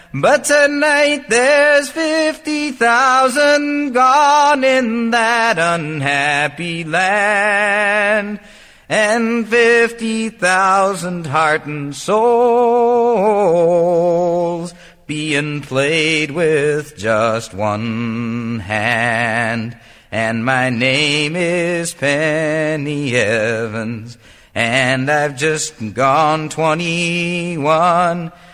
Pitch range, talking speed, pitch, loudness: 145-230 Hz, 70 wpm, 170 Hz, -15 LUFS